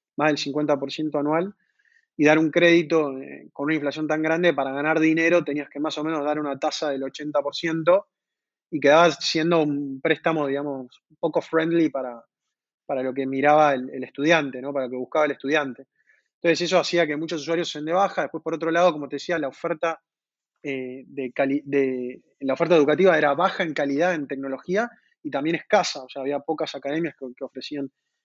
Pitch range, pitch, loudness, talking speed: 140-165 Hz, 155 Hz, -23 LUFS, 200 wpm